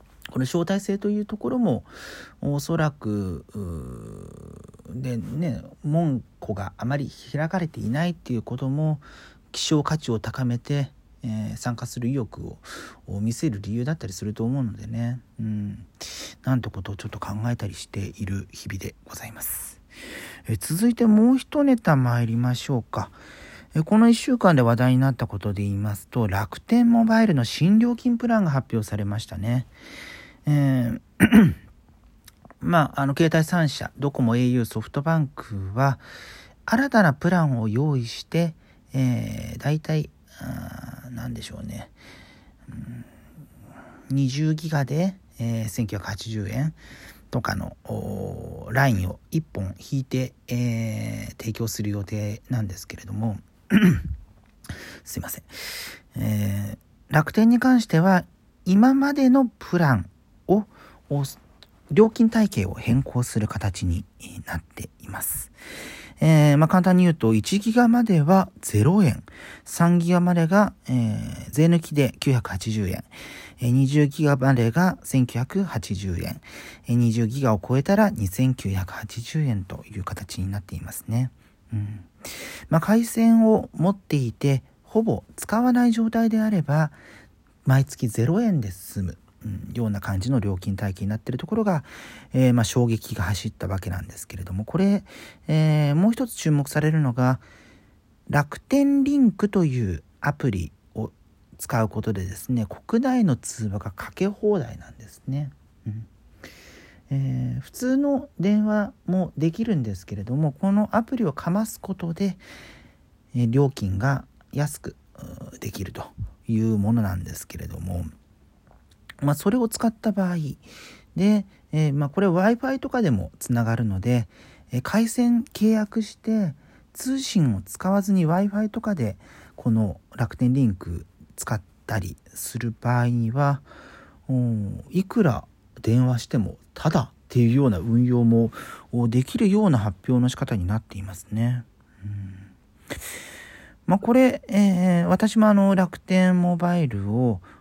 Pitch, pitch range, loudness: 125 Hz, 105-175 Hz, -23 LUFS